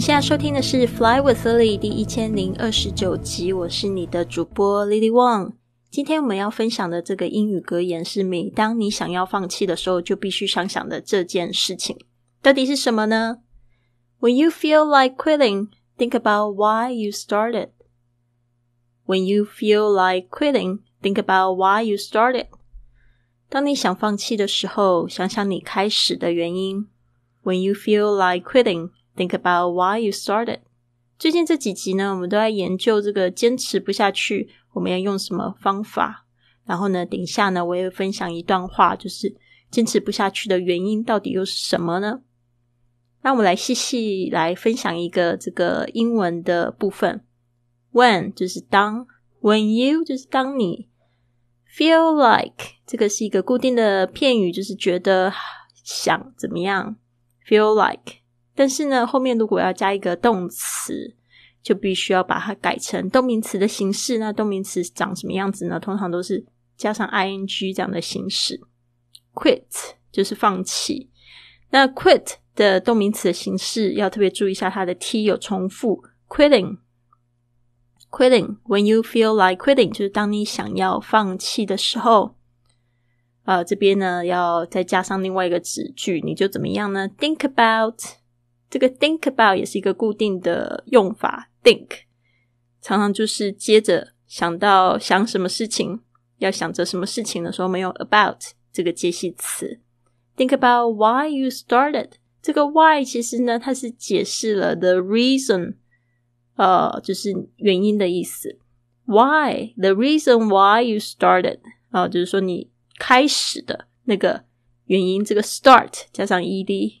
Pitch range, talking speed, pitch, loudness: 175-220 Hz, 355 characters per minute, 195 Hz, -20 LUFS